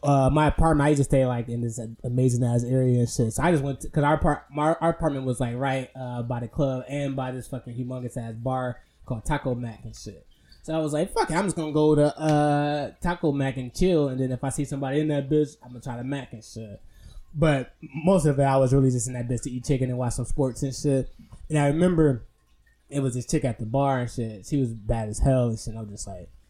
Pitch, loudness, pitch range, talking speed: 130 Hz, -25 LUFS, 120-150 Hz, 270 wpm